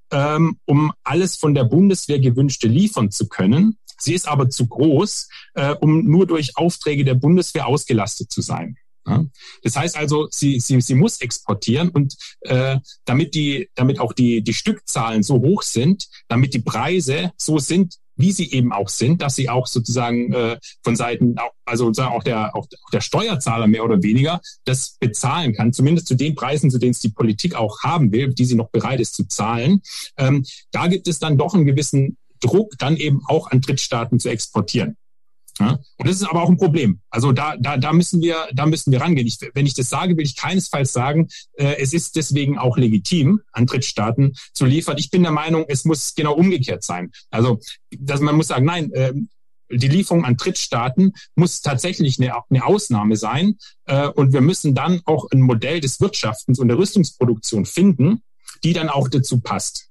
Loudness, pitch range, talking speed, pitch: -18 LUFS, 125-165 Hz, 185 wpm, 140 Hz